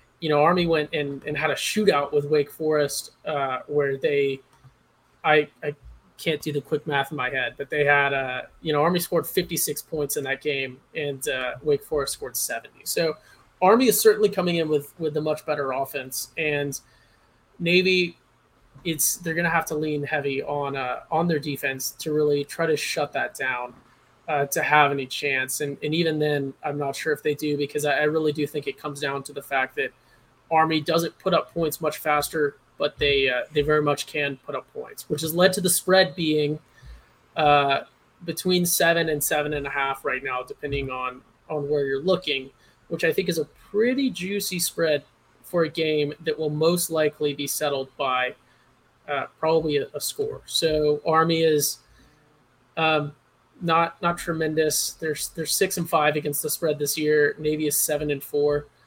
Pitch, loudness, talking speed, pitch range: 150 Hz, -24 LUFS, 195 wpm, 140-160 Hz